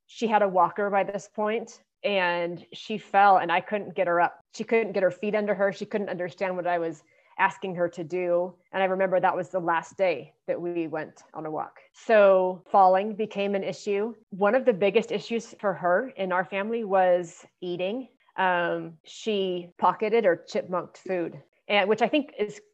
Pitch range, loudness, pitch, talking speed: 180-210 Hz, -26 LUFS, 195 Hz, 200 wpm